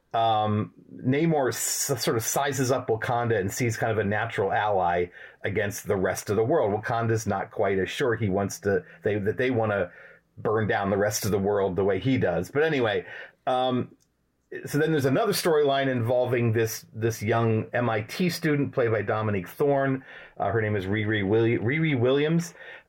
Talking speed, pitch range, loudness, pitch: 185 wpm, 105-135 Hz, -26 LUFS, 115 Hz